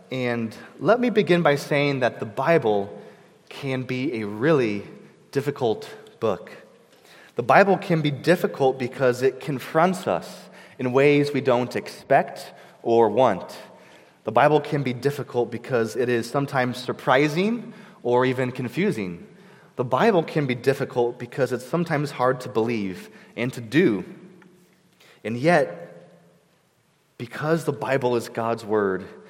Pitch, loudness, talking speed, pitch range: 130 Hz, -23 LUFS, 135 wpm, 120-165 Hz